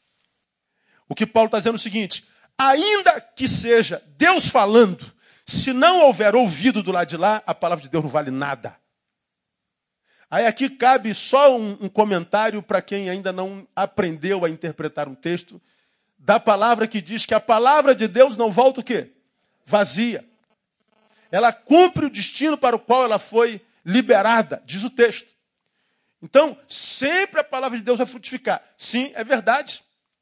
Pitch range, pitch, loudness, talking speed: 195-255 Hz, 225 Hz, -19 LUFS, 165 wpm